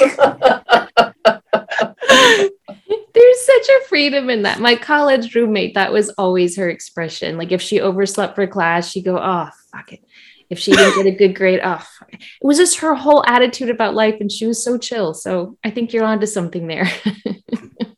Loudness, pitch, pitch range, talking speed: -15 LUFS, 220 Hz, 190-250 Hz, 180 wpm